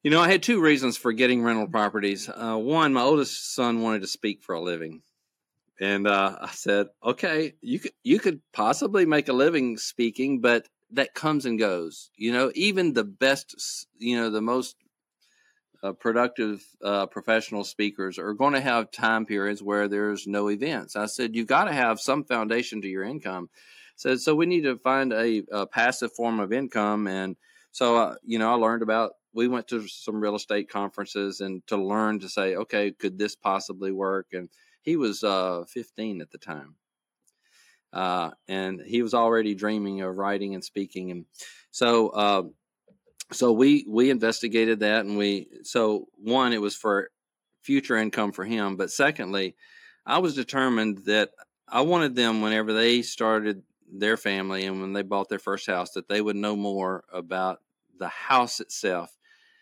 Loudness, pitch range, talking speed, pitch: -25 LUFS, 100-120 Hz, 180 wpm, 110 Hz